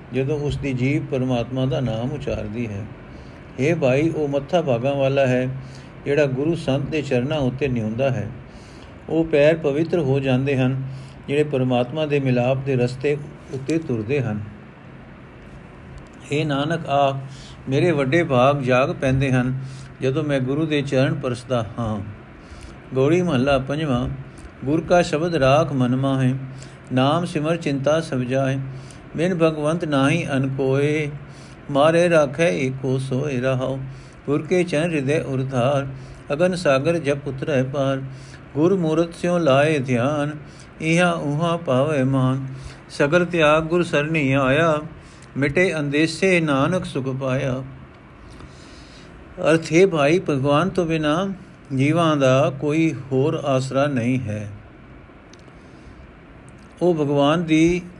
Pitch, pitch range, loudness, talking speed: 140 Hz, 130-155 Hz, -21 LUFS, 125 wpm